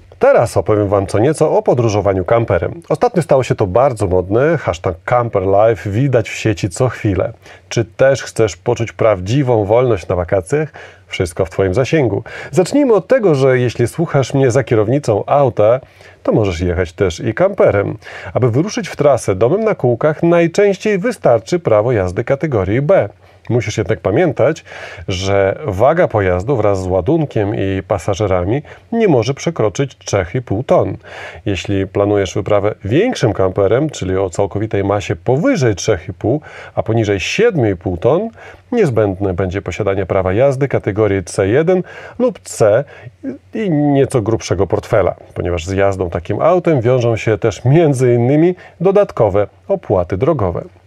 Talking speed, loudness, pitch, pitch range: 140 wpm, -15 LUFS, 110 Hz, 100-140 Hz